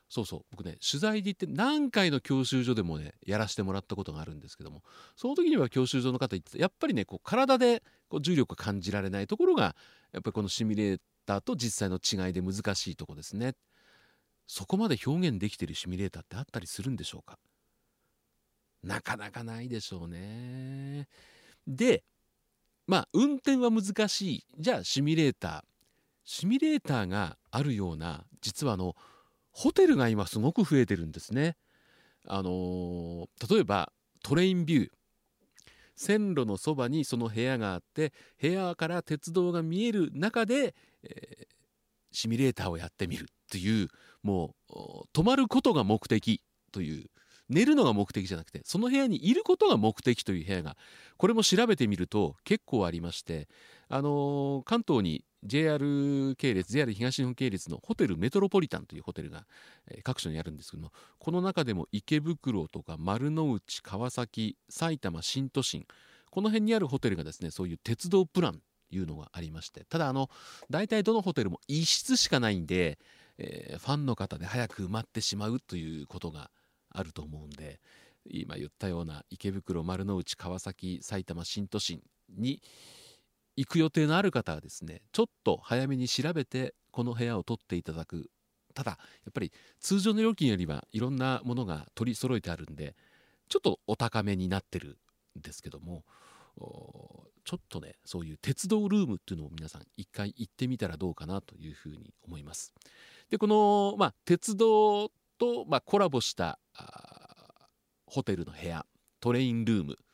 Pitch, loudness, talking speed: 120 Hz, -31 LUFS, 345 characters per minute